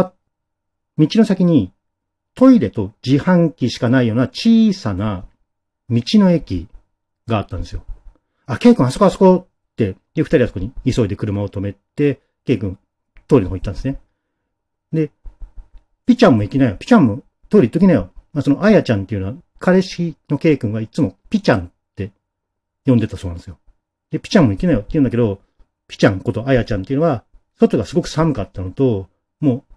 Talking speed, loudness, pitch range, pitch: 380 characters per minute, -17 LUFS, 100-150 Hz, 110 Hz